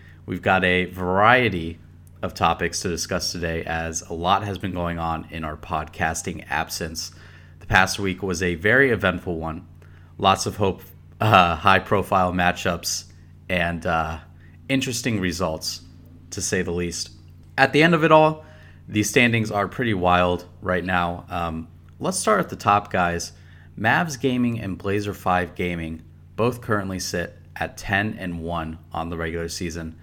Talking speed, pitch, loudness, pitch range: 160 wpm, 90 Hz, -22 LUFS, 85-95 Hz